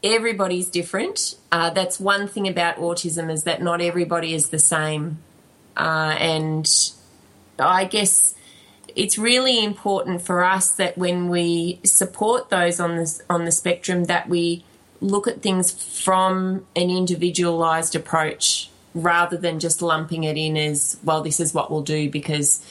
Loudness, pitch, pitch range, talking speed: -20 LUFS, 175 Hz, 160-185 Hz, 150 wpm